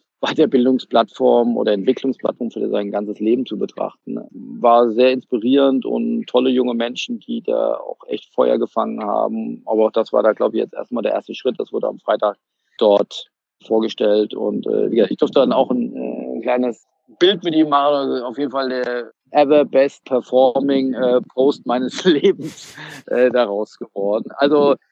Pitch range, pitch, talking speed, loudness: 120-140 Hz, 130 Hz, 175 wpm, -18 LUFS